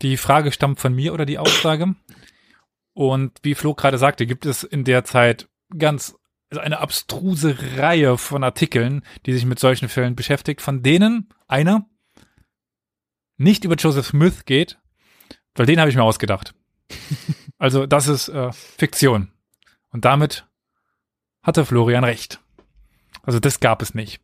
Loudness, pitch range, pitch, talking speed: -19 LUFS, 125-155 Hz, 140 Hz, 150 wpm